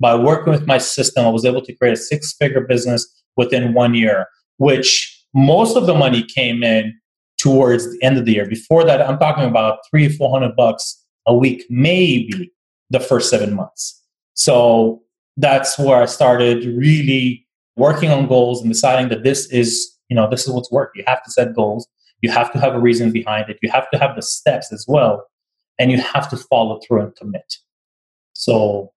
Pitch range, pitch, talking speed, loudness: 115-135 Hz, 125 Hz, 200 wpm, -15 LUFS